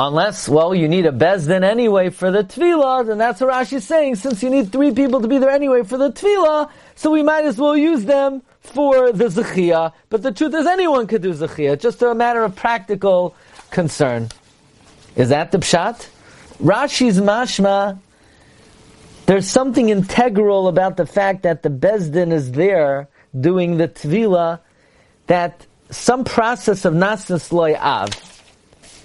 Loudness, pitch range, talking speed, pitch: -17 LUFS, 175-260 Hz, 165 wpm, 205 Hz